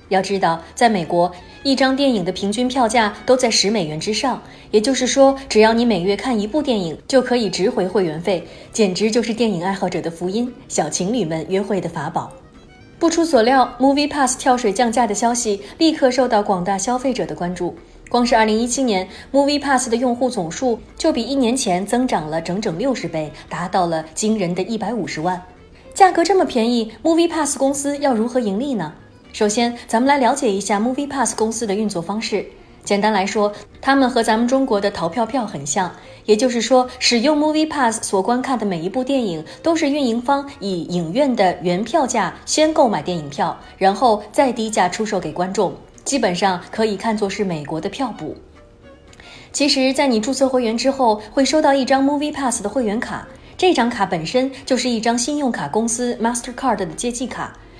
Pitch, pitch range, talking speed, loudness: 230 Hz, 195-260 Hz, 335 characters per minute, -18 LUFS